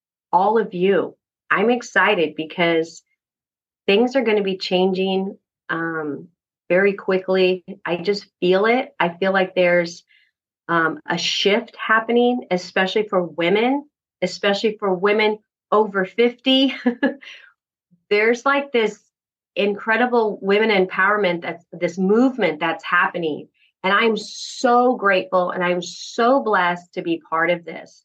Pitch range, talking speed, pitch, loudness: 175-220 Hz, 125 wpm, 195 Hz, -19 LUFS